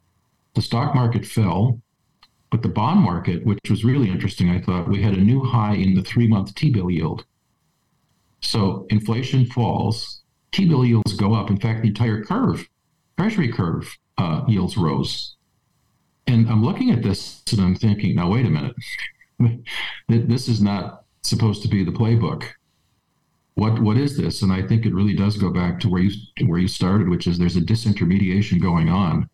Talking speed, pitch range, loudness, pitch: 175 wpm, 95-120 Hz, -20 LUFS, 110 Hz